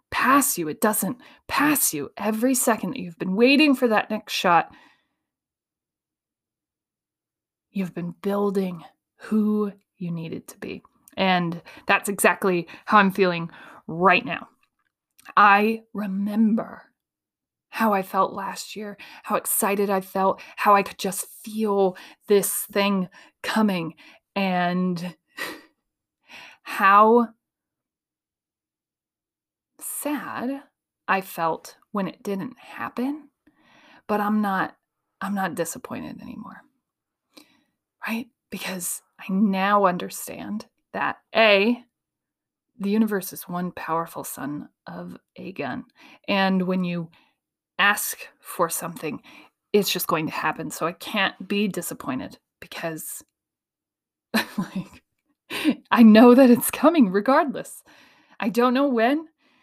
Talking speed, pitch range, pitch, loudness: 110 wpm, 190-240 Hz, 205 Hz, -22 LUFS